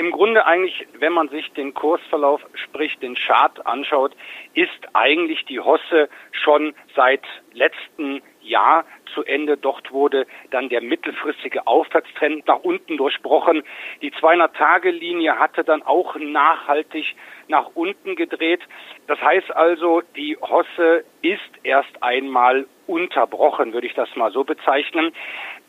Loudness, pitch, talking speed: -19 LUFS, 165 Hz, 130 wpm